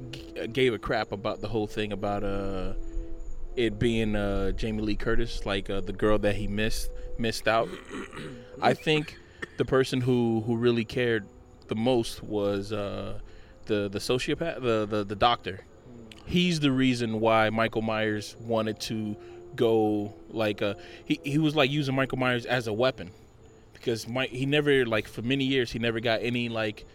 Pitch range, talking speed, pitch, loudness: 105-120 Hz, 170 wpm, 110 Hz, -28 LUFS